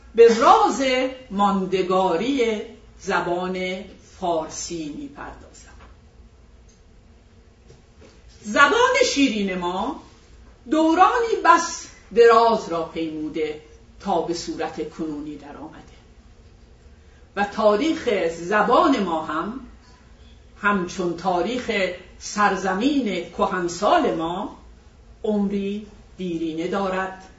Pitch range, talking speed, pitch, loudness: 175-245 Hz, 75 wpm, 200 Hz, -21 LUFS